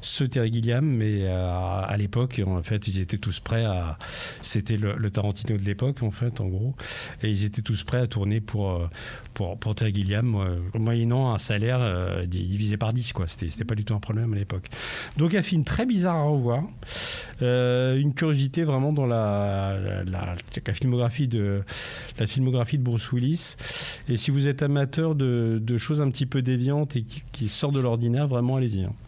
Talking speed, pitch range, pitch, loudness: 205 wpm, 100-130 Hz, 115 Hz, -26 LUFS